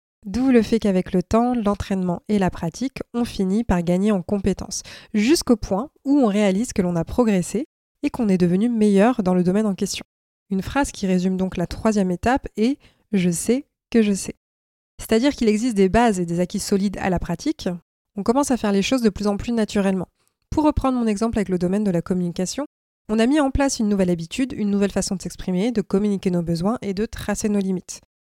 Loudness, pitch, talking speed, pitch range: -21 LUFS, 205 Hz, 220 wpm, 185-235 Hz